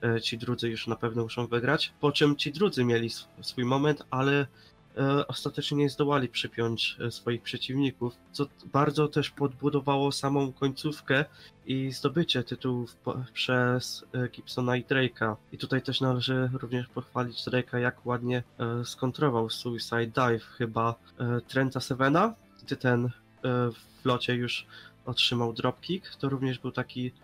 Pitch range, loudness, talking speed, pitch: 120-140 Hz, -29 LUFS, 130 wpm, 125 Hz